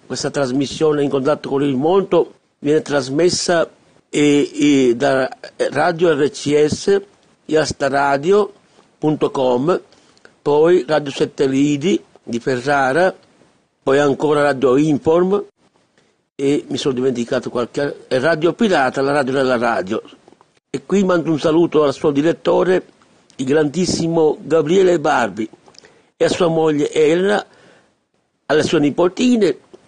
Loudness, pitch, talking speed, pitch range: -17 LUFS, 145 Hz, 115 wpm, 140-165 Hz